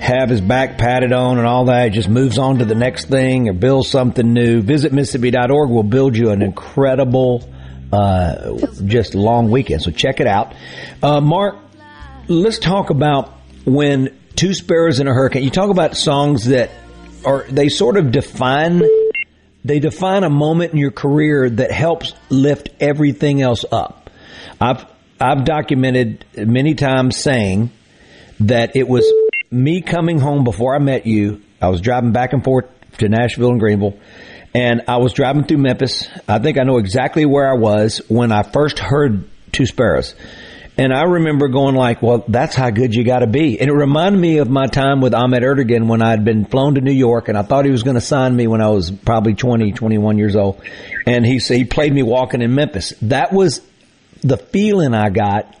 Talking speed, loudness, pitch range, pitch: 190 wpm, -15 LUFS, 115-145 Hz, 130 Hz